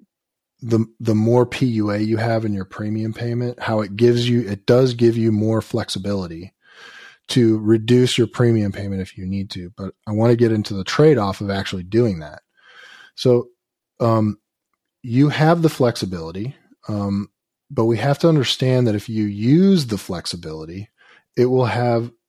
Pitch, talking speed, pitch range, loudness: 115 Hz, 170 wpm, 100-120 Hz, -19 LUFS